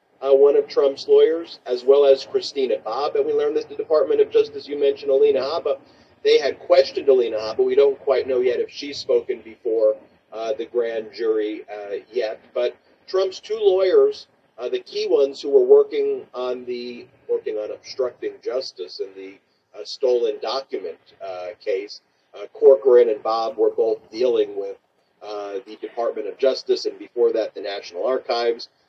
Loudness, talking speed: -21 LUFS, 175 wpm